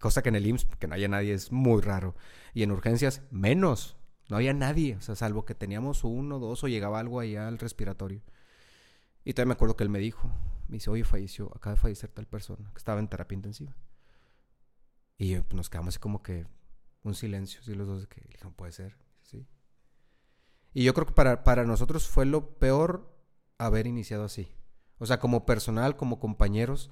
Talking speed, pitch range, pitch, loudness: 205 wpm, 100-130 Hz, 110 Hz, -30 LUFS